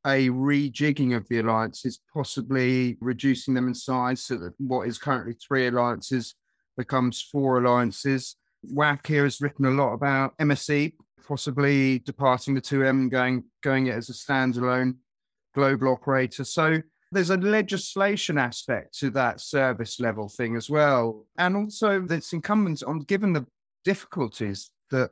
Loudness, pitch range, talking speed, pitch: -25 LUFS, 125-145 Hz, 150 wpm, 135 Hz